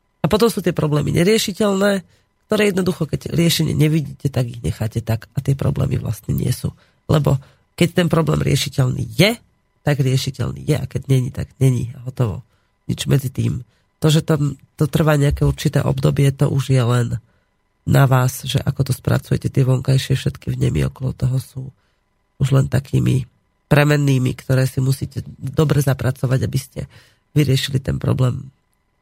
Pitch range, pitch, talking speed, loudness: 130-150 Hz, 135 Hz, 165 wpm, -19 LUFS